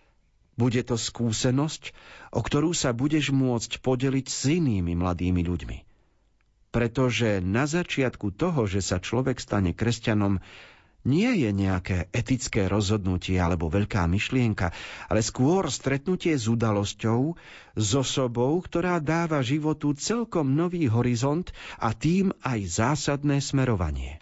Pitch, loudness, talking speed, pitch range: 125 Hz, -26 LUFS, 120 wpm, 100-145 Hz